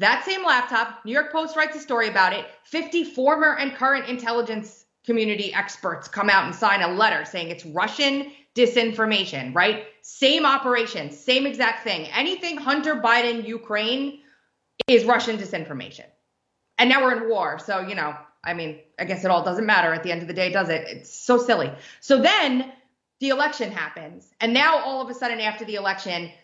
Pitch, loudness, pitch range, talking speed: 230 Hz, -22 LUFS, 195-265 Hz, 185 wpm